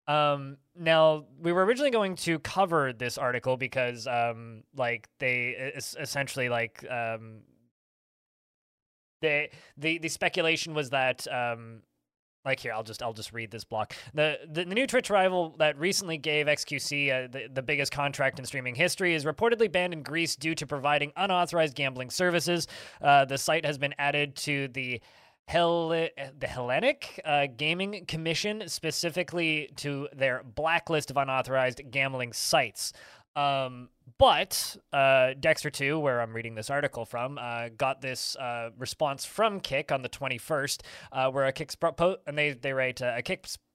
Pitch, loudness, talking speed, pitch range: 140 Hz, -28 LUFS, 165 wpm, 125-160 Hz